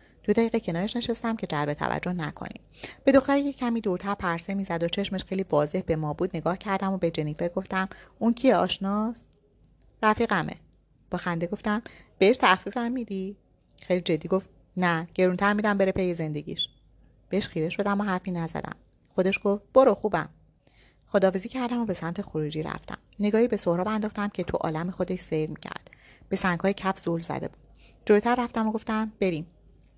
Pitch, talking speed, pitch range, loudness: 190 Hz, 170 wpm, 175-215 Hz, -27 LUFS